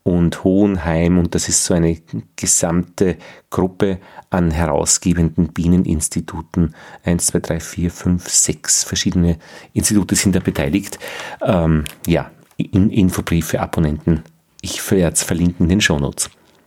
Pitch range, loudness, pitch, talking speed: 85-95 Hz, -17 LUFS, 85 Hz, 125 wpm